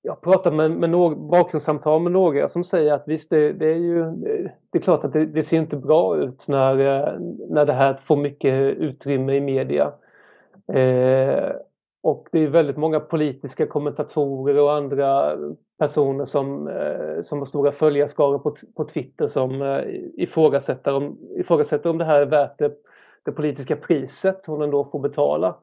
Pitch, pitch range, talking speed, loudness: 150 Hz, 140-160 Hz, 175 wpm, -21 LUFS